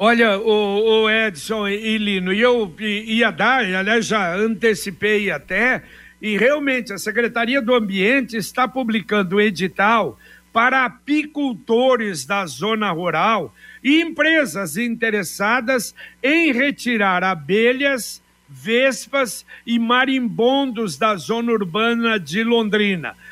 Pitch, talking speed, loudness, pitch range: 225 Hz, 105 wpm, -18 LUFS, 205-250 Hz